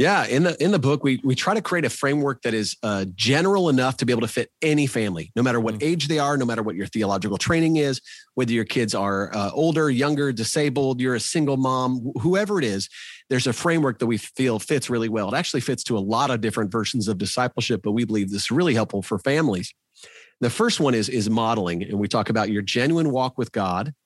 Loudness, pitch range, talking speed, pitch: -22 LUFS, 110-140 Hz, 240 wpm, 125 Hz